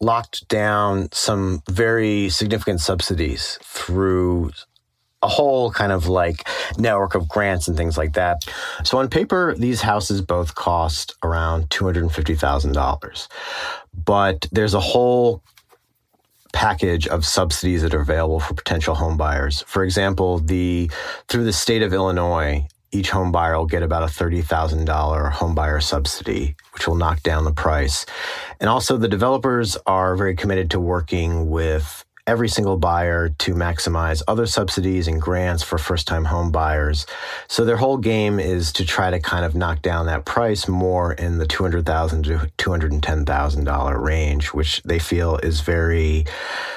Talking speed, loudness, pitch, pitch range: 150 wpm, -20 LUFS, 85 Hz, 80-95 Hz